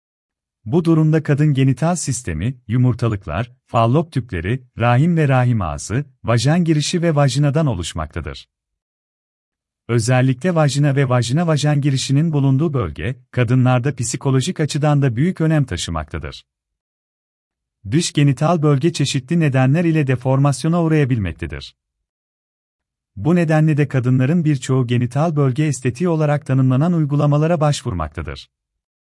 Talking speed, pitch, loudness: 105 wpm, 130 Hz, -17 LUFS